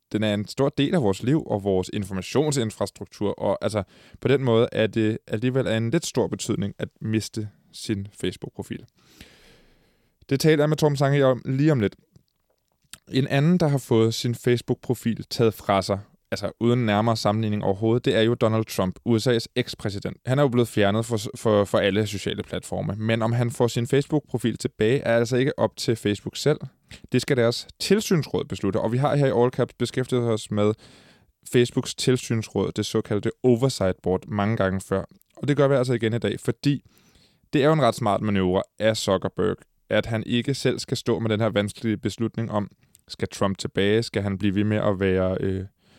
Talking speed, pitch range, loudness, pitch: 195 wpm, 105-130 Hz, -24 LUFS, 115 Hz